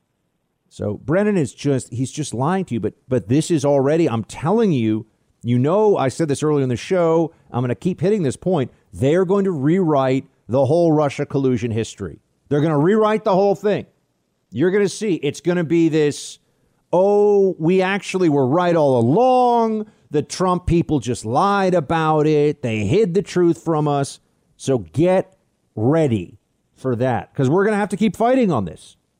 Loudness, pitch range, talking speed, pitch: -19 LUFS, 130-185 Hz, 185 wpm, 155 Hz